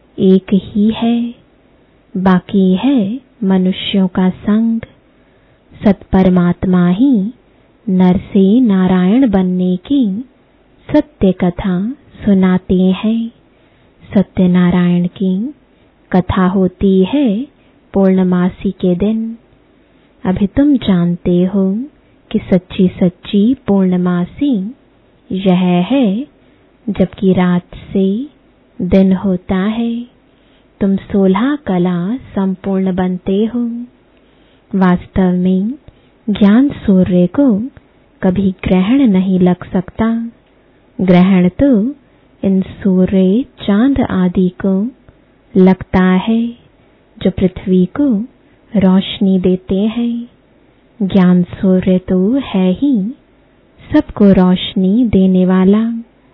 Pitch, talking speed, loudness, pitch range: 195 Hz, 90 wpm, -13 LUFS, 185-230 Hz